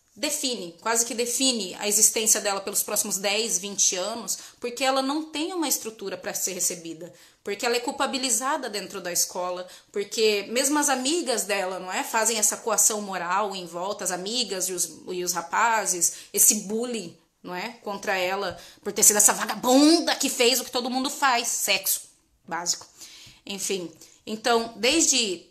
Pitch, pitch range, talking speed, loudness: 210 Hz, 190-245 Hz, 165 wpm, -23 LUFS